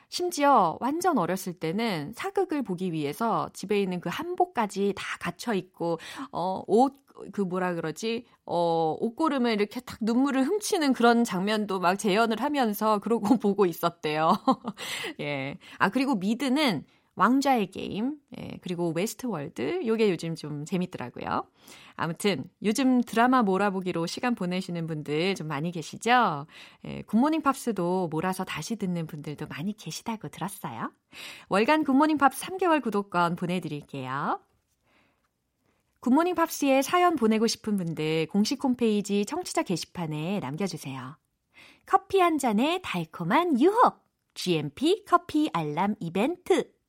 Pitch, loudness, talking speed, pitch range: 210 Hz, -27 LUFS, 300 characters per minute, 175-265 Hz